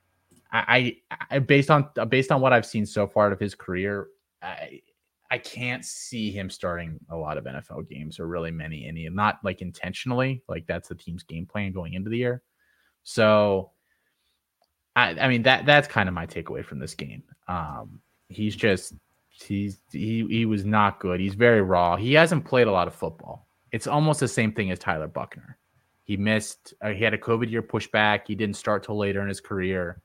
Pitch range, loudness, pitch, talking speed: 95-120 Hz, -24 LUFS, 105 Hz, 200 wpm